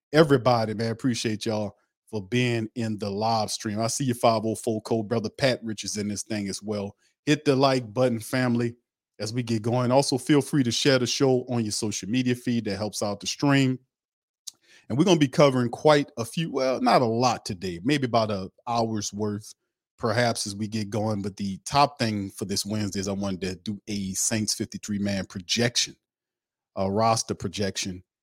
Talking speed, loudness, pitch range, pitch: 200 wpm, -25 LUFS, 105-125 Hz, 115 Hz